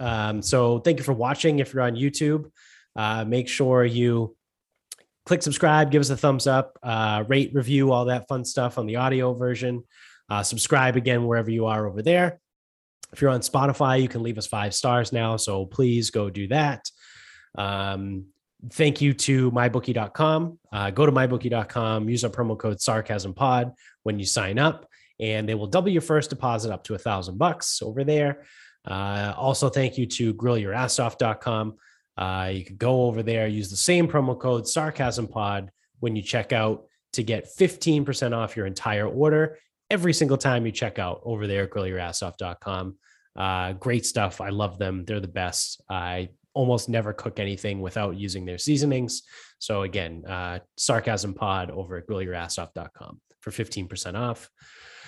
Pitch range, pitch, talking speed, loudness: 100-130 Hz, 115 Hz, 170 wpm, -25 LUFS